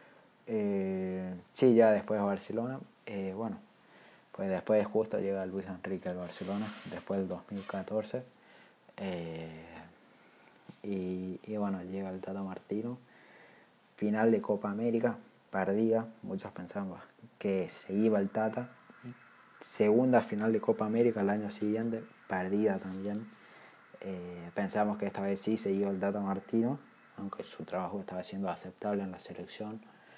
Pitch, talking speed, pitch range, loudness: 100 Hz, 135 wpm, 95-110 Hz, -34 LUFS